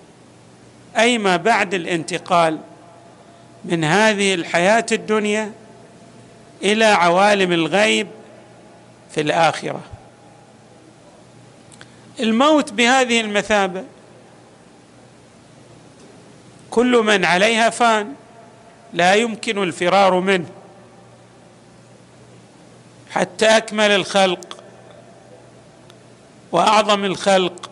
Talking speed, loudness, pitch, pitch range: 60 wpm, -17 LUFS, 200 Hz, 175-220 Hz